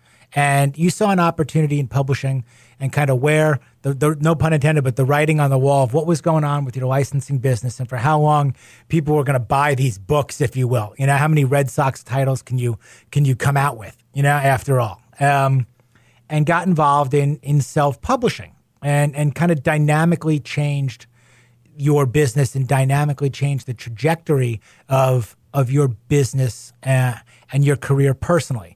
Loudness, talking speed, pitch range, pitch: -18 LUFS, 190 wpm, 130-150 Hz, 140 Hz